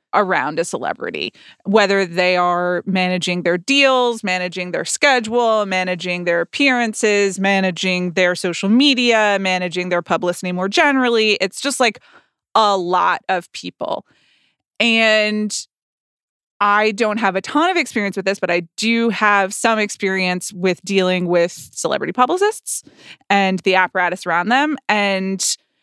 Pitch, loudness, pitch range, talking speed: 195 Hz, -17 LUFS, 180-225 Hz, 135 wpm